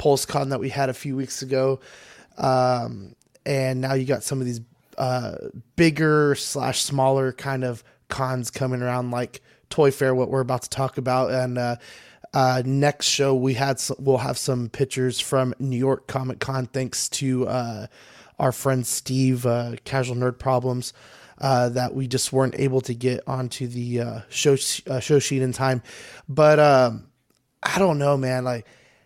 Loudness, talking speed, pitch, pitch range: -23 LUFS, 180 wpm, 130 Hz, 125-135 Hz